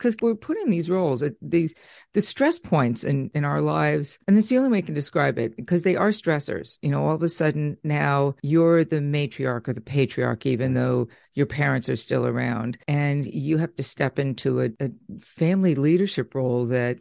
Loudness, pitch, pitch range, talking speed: -23 LUFS, 145 Hz, 130-170 Hz, 205 wpm